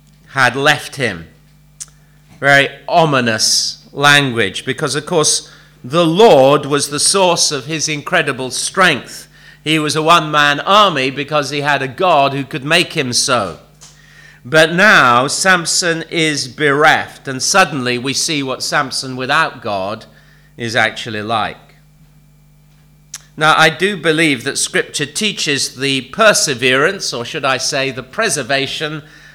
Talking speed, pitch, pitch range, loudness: 135 wpm, 150 Hz, 135-155 Hz, -13 LUFS